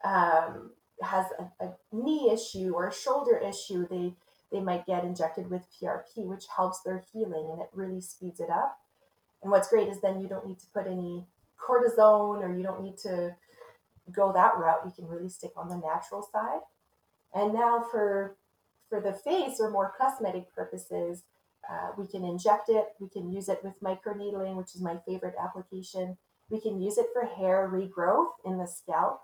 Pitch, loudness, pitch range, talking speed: 190 Hz, -30 LUFS, 180-210 Hz, 185 wpm